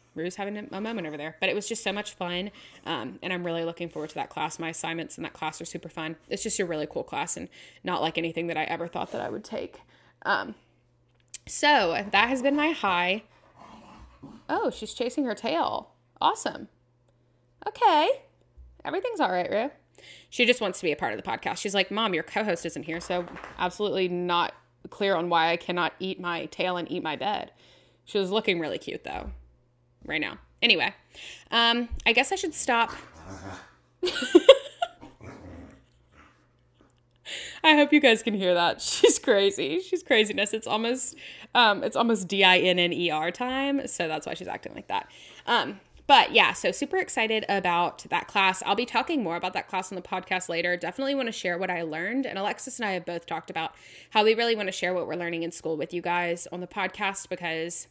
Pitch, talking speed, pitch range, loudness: 190 Hz, 200 wpm, 170-235 Hz, -26 LUFS